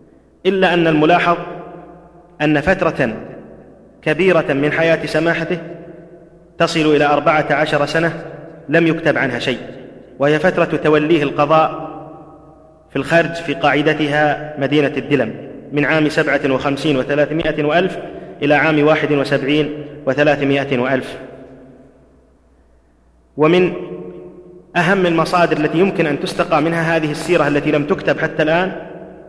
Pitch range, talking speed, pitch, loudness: 145-165 Hz, 115 wpm, 155 Hz, -16 LUFS